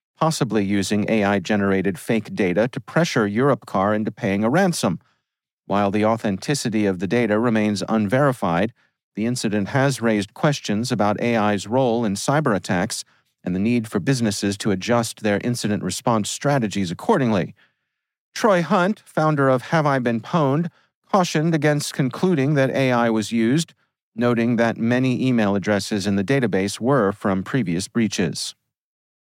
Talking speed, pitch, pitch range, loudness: 140 wpm, 115 Hz, 105-135 Hz, -21 LUFS